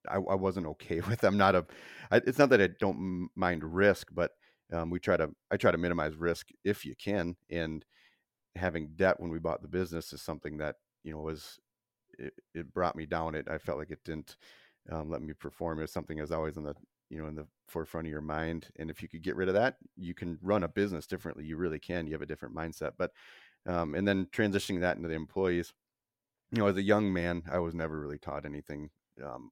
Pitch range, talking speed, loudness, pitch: 80-90 Hz, 240 wpm, -33 LUFS, 85 Hz